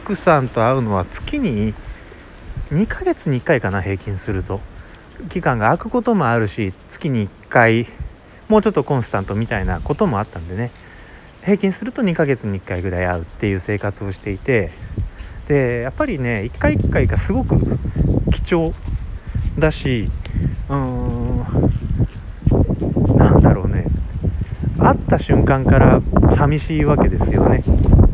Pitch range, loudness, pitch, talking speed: 95-140 Hz, -18 LUFS, 110 Hz, 265 characters per minute